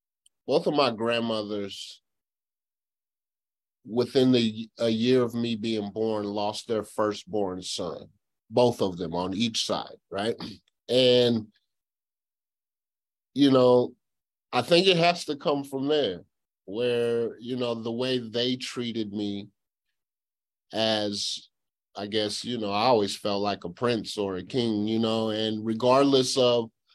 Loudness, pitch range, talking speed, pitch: -26 LUFS, 105-125 Hz, 135 wpm, 115 Hz